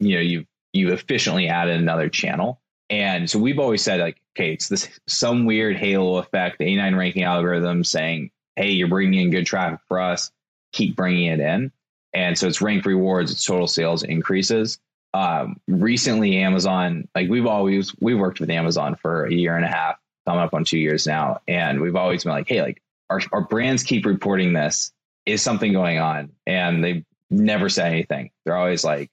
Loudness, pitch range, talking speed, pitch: -21 LUFS, 85-100 Hz, 195 wpm, 90 Hz